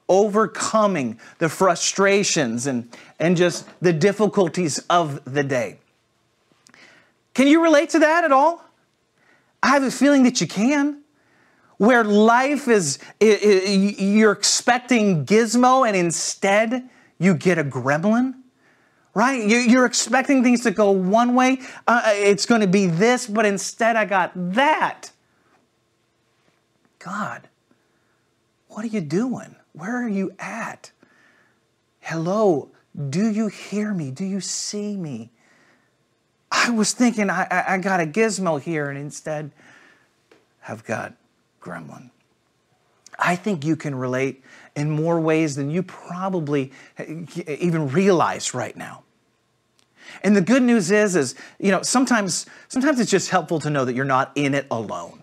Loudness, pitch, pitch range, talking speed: -20 LUFS, 200 Hz, 165-235 Hz, 140 wpm